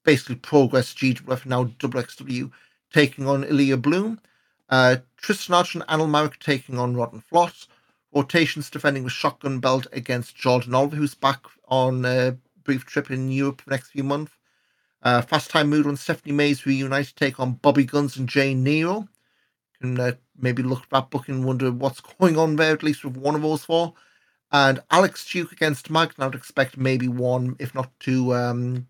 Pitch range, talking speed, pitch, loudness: 130-150 Hz, 190 wpm, 135 Hz, -22 LUFS